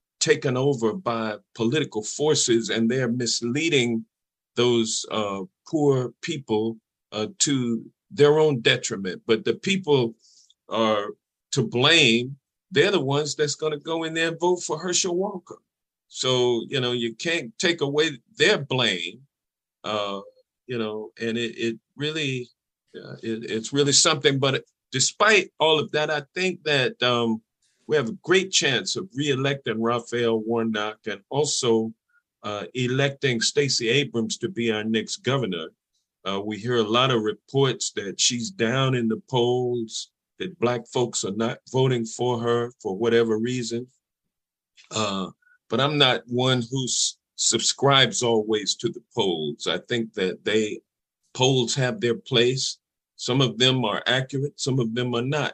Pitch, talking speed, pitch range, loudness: 125 Hz, 150 wpm, 115-145 Hz, -23 LUFS